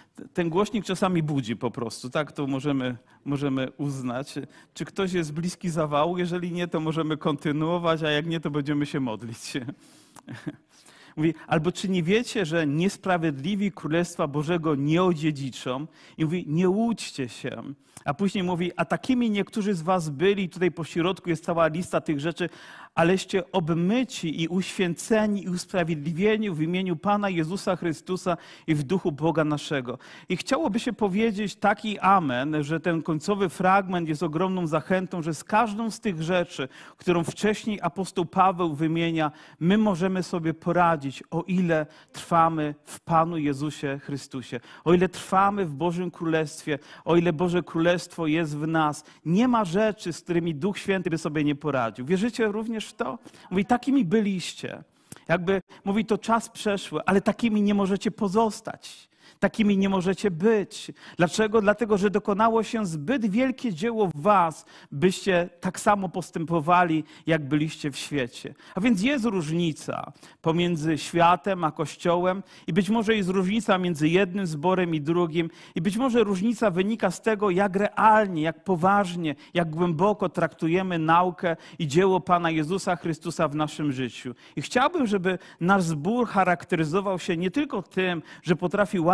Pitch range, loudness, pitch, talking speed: 160-200 Hz, -25 LUFS, 175 Hz, 155 wpm